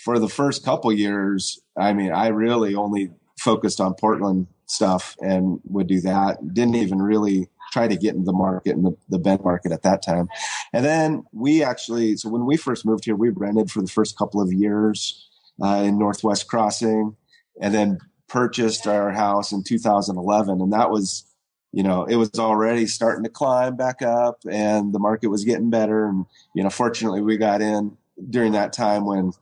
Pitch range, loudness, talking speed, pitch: 100-115 Hz, -21 LUFS, 190 wpm, 105 Hz